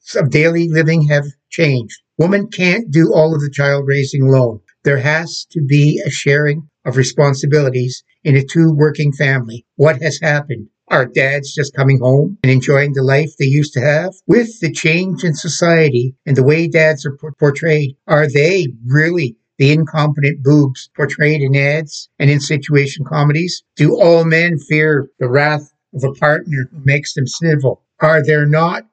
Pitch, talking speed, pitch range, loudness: 150 Hz, 175 wpm, 140-160 Hz, -14 LUFS